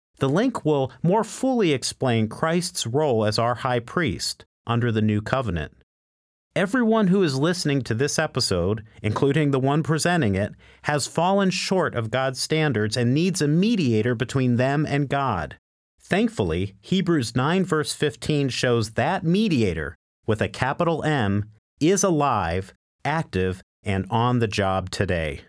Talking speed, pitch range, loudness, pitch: 145 wpm, 105-160 Hz, -23 LUFS, 130 Hz